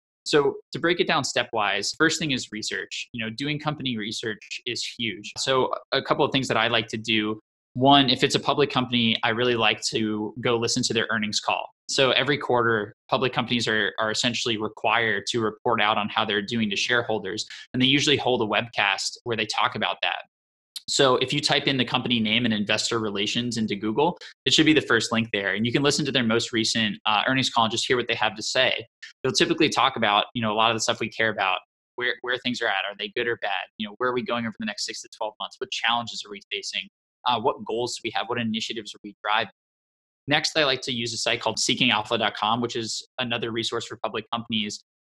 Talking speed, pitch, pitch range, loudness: 240 wpm, 115 Hz, 110-130 Hz, -24 LUFS